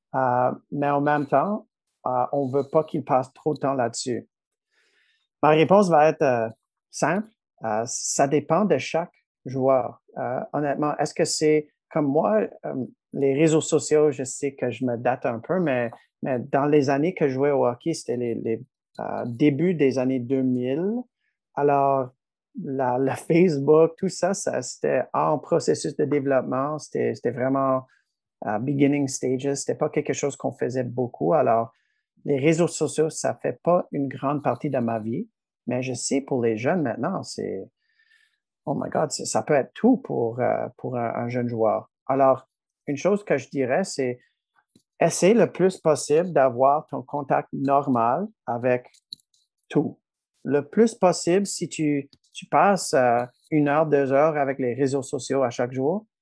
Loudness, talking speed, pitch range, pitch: -24 LUFS, 170 wpm, 130-160 Hz, 140 Hz